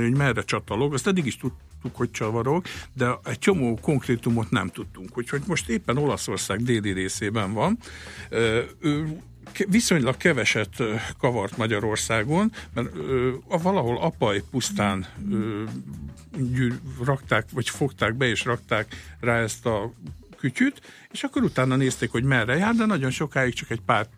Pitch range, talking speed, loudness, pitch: 105-135 Hz, 135 wpm, -25 LUFS, 120 Hz